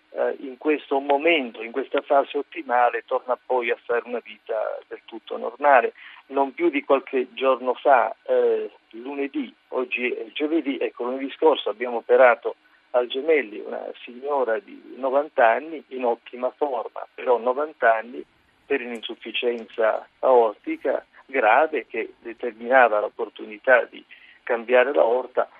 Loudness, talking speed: -23 LUFS, 130 wpm